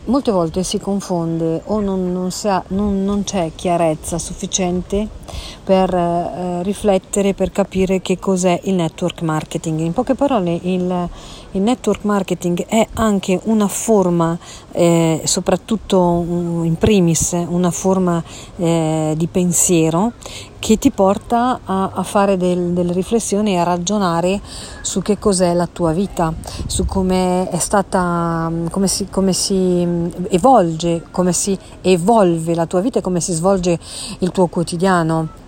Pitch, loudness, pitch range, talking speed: 180 Hz, -17 LUFS, 170-195 Hz, 140 wpm